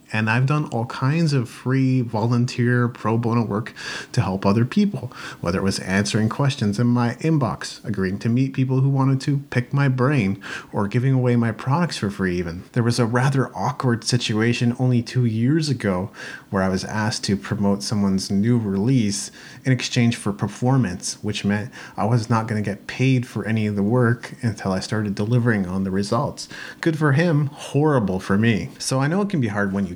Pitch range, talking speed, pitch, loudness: 105-130 Hz, 200 wpm, 120 Hz, -21 LUFS